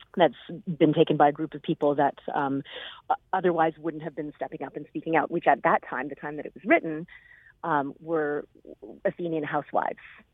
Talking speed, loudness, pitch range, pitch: 190 wpm, -27 LUFS, 145-165 Hz, 155 Hz